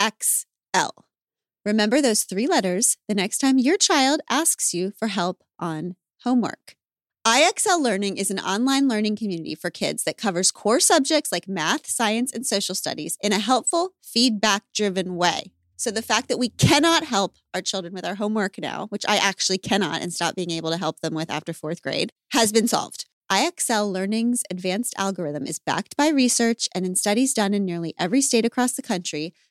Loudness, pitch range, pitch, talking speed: -22 LUFS, 180-245 Hz, 205 Hz, 185 wpm